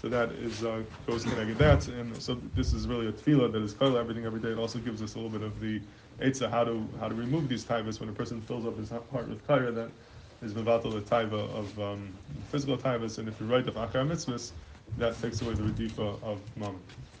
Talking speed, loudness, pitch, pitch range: 235 wpm, -32 LUFS, 115 Hz, 110-120 Hz